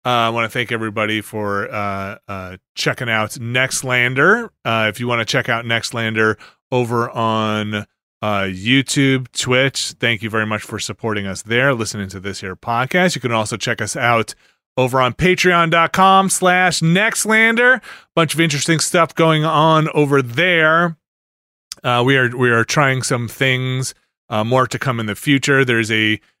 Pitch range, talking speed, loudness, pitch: 110-150 Hz, 170 wpm, -16 LUFS, 125 Hz